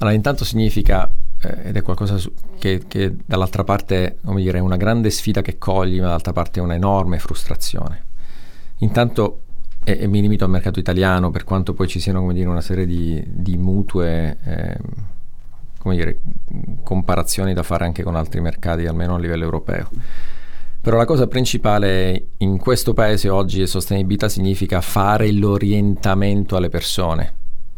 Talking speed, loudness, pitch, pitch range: 160 wpm, -20 LUFS, 95 Hz, 90-105 Hz